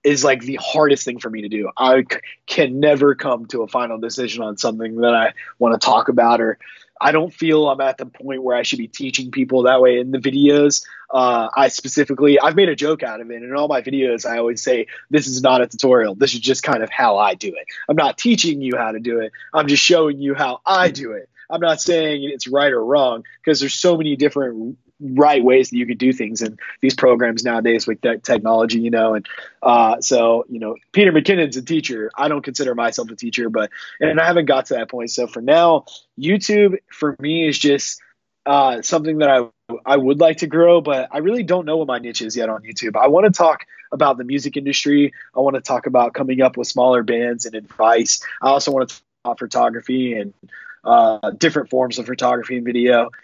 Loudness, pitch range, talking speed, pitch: -17 LUFS, 120-150 Hz, 235 wpm, 130 Hz